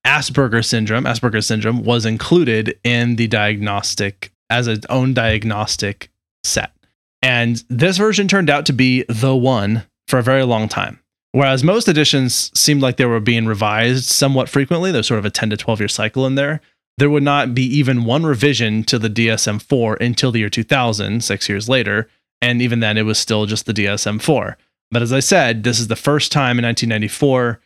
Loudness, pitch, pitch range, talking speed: -16 LUFS, 120 Hz, 110-135 Hz, 190 wpm